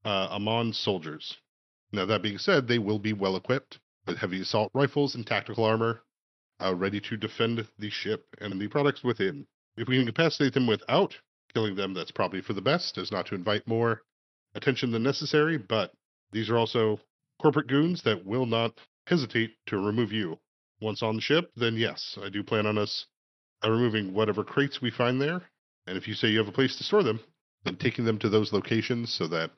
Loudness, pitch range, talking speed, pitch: -28 LUFS, 105-125 Hz, 205 wpm, 115 Hz